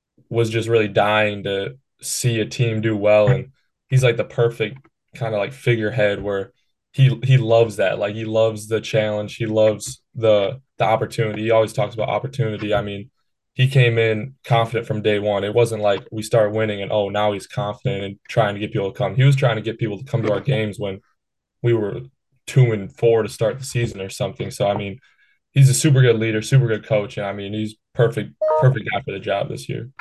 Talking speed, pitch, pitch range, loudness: 225 wpm, 110 Hz, 105-125 Hz, -20 LUFS